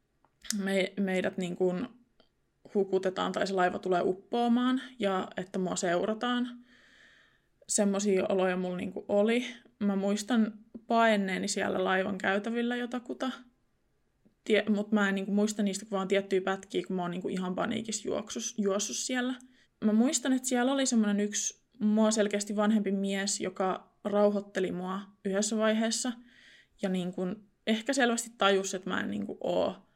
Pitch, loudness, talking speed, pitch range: 205 Hz, -30 LUFS, 145 wpm, 195-230 Hz